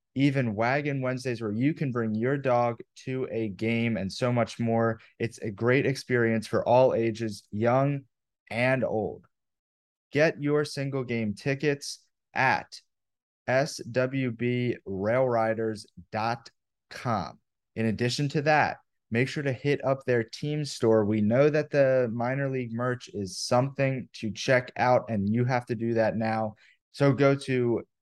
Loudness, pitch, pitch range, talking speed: -27 LUFS, 125 Hz, 115-135 Hz, 145 wpm